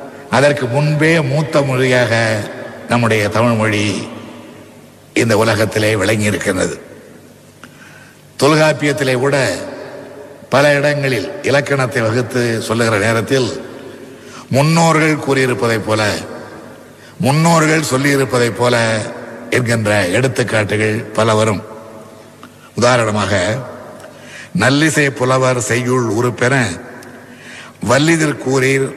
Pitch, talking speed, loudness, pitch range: 125 Hz, 75 wpm, -14 LUFS, 110-140 Hz